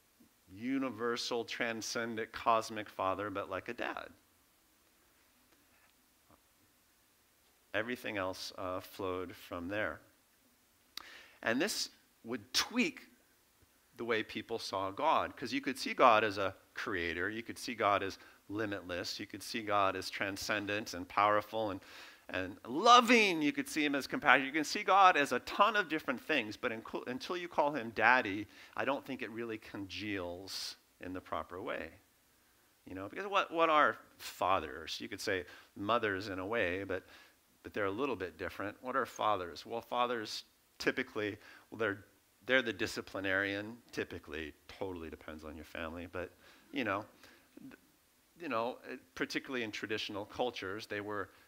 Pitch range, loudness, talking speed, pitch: 100-130 Hz, -35 LUFS, 150 wpm, 110 Hz